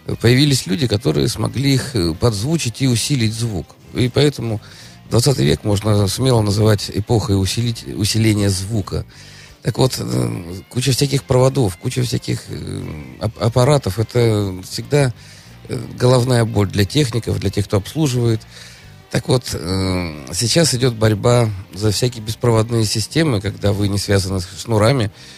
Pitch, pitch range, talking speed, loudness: 110 Hz, 95-125 Hz, 125 wpm, -18 LUFS